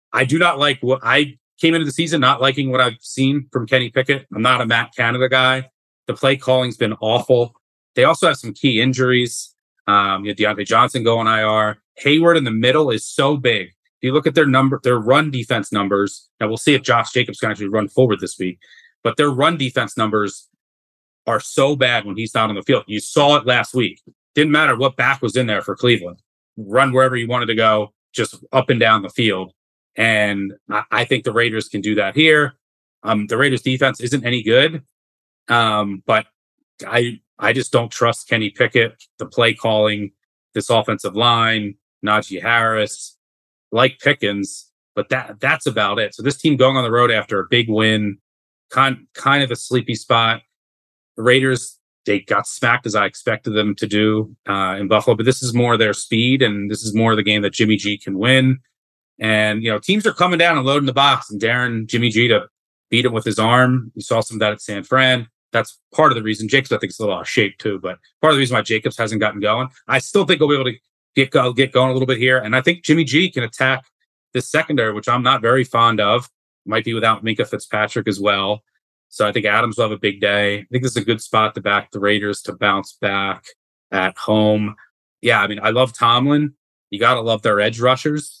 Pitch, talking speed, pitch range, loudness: 120 Hz, 220 wpm, 105-130 Hz, -17 LUFS